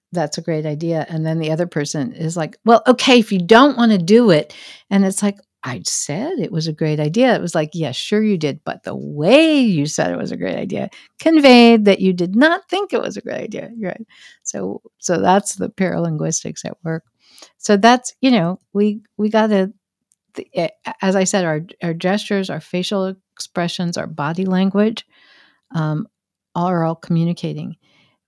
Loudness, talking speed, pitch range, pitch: -17 LUFS, 190 wpm, 160-220 Hz, 190 Hz